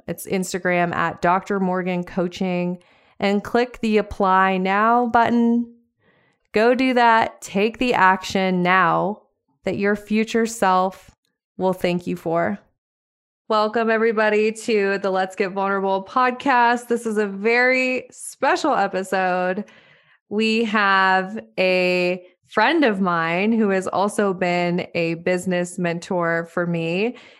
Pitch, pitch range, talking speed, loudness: 195 Hz, 180-225 Hz, 125 wpm, -20 LUFS